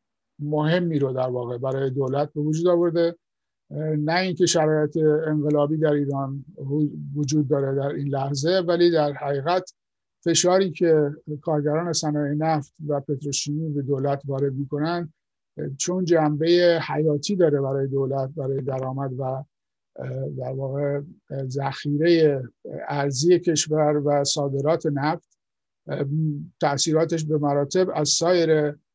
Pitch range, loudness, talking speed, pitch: 140-160 Hz, -23 LUFS, 115 wpm, 150 Hz